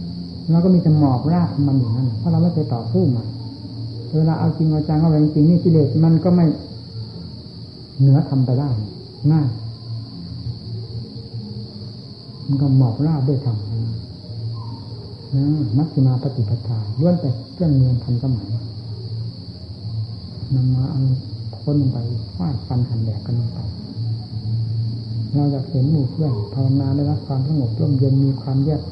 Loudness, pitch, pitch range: -19 LUFS, 125 Hz, 115-145 Hz